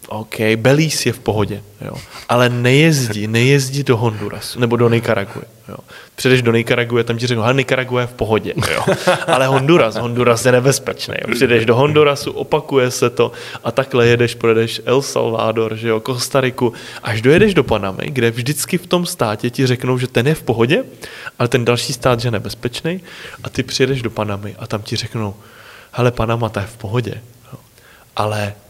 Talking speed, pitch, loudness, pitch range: 180 wpm, 120 Hz, -16 LUFS, 115-130 Hz